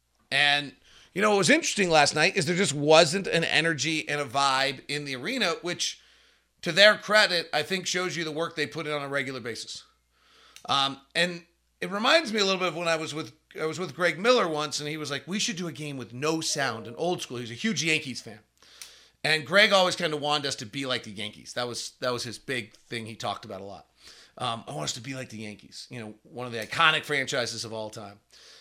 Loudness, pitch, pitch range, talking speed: -25 LUFS, 150 Hz, 125-175 Hz, 250 wpm